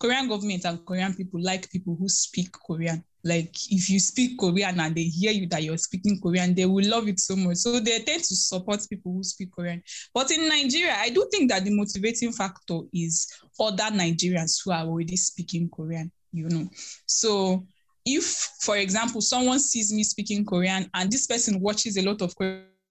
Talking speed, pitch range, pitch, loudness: 195 wpm, 175-215 Hz, 190 Hz, -25 LUFS